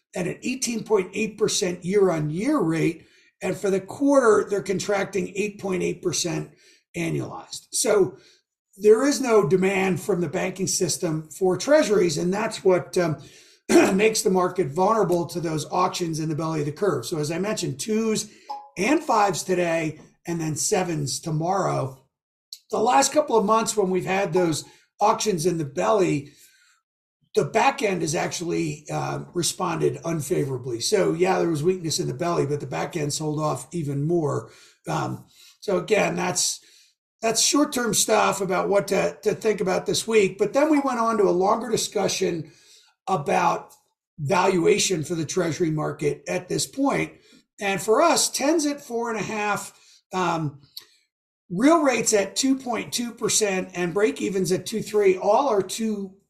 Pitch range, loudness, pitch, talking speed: 175-220 Hz, -23 LUFS, 195 Hz, 160 wpm